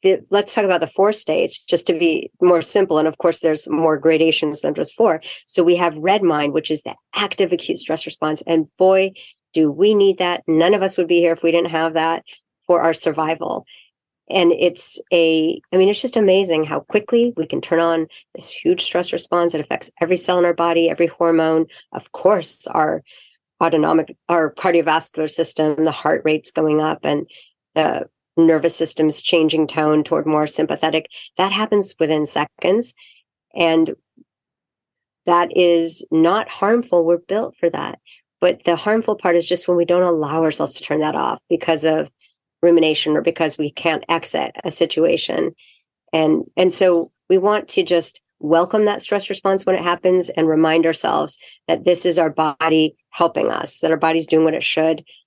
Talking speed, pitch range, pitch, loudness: 185 wpm, 160-180 Hz, 170 Hz, -18 LUFS